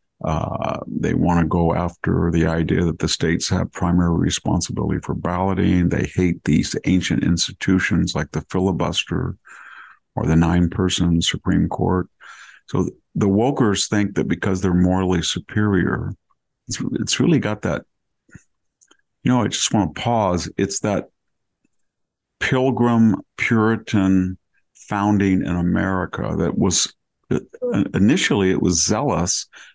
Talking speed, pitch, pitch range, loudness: 125 wpm, 90 Hz, 85-95 Hz, -20 LUFS